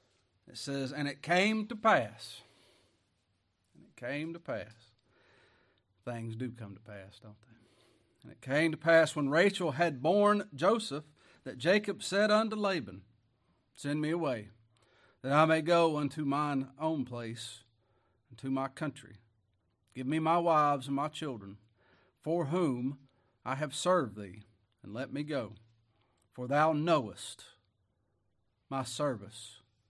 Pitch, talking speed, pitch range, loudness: 125 Hz, 140 wpm, 110-150 Hz, -32 LUFS